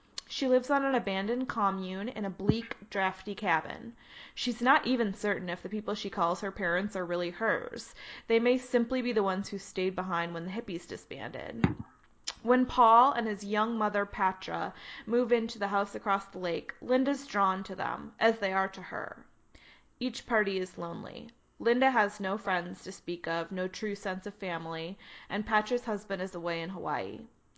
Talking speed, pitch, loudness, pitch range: 185 wpm, 200 Hz, -31 LUFS, 185-230 Hz